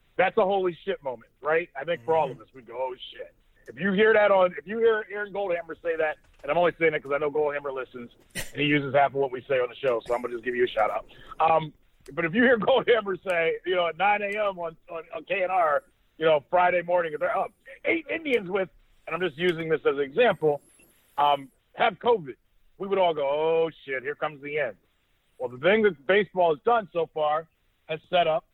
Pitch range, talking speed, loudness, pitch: 155-210 Hz, 245 wpm, -25 LUFS, 175 Hz